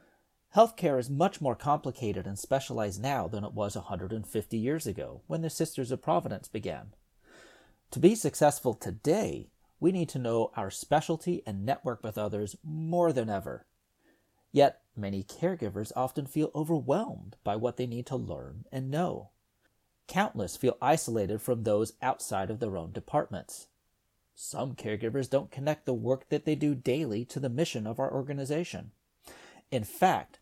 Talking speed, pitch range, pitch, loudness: 155 wpm, 110-150 Hz, 130 Hz, -31 LUFS